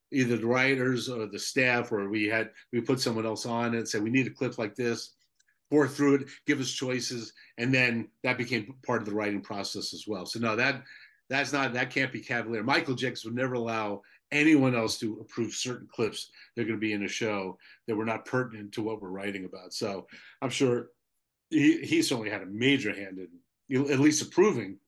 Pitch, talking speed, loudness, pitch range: 120 Hz, 215 wpm, -29 LUFS, 110-130 Hz